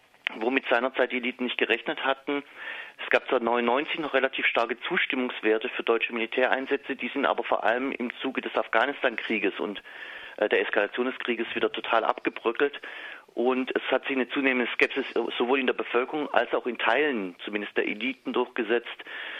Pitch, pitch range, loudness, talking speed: 125 Hz, 120-135 Hz, -27 LUFS, 165 wpm